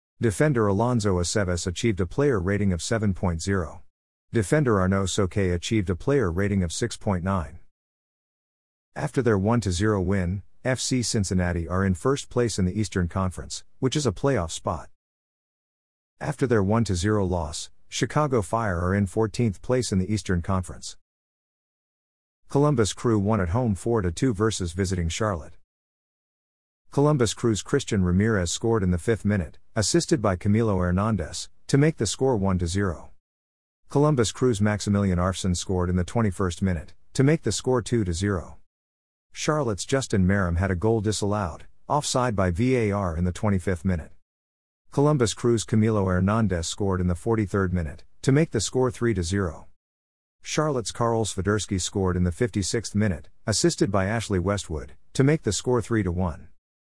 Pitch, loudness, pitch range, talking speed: 100 Hz, -25 LUFS, 90-115 Hz, 145 wpm